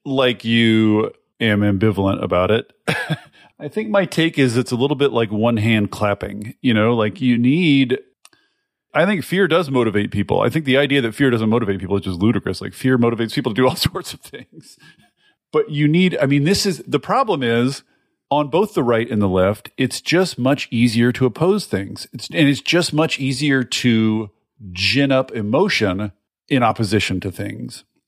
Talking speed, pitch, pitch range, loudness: 190 wpm, 125 Hz, 110-145 Hz, -18 LUFS